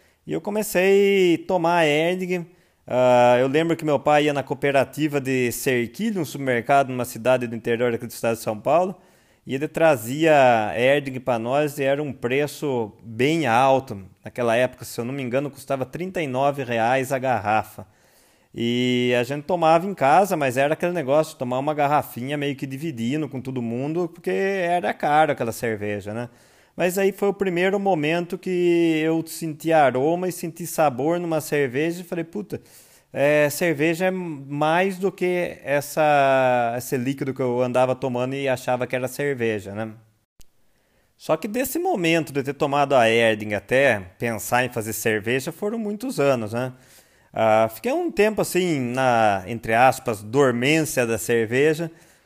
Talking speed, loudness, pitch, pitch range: 165 wpm, -22 LUFS, 140 Hz, 125-165 Hz